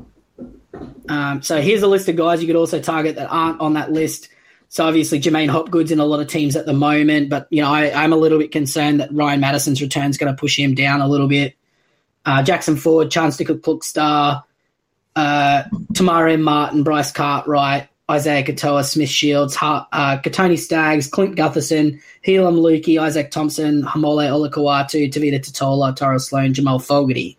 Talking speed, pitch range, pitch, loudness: 185 wpm, 140-160 Hz, 150 Hz, -17 LUFS